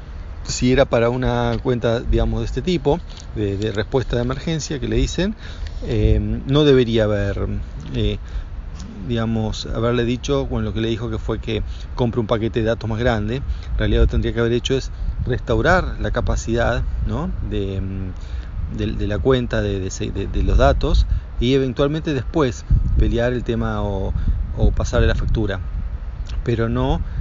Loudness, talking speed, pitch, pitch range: -21 LUFS, 170 wpm, 110 Hz, 100-120 Hz